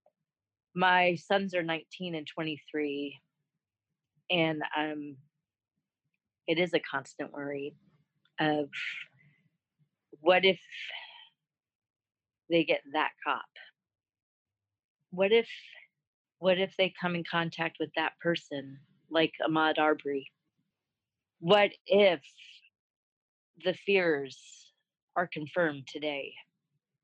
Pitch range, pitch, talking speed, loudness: 150-180 Hz, 160 Hz, 90 wpm, -30 LUFS